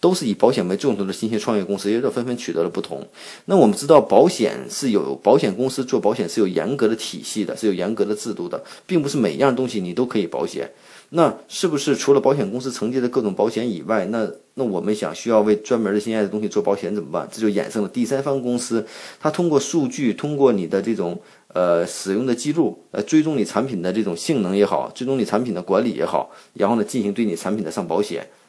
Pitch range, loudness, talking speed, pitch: 105-135 Hz, -21 LUFS, 360 characters per minute, 115 Hz